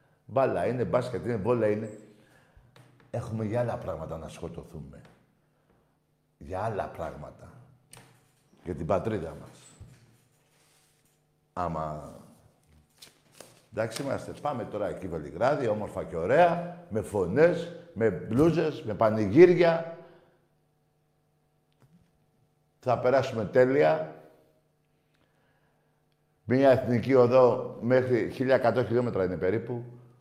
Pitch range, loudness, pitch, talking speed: 105-150 Hz, -27 LUFS, 125 Hz, 90 wpm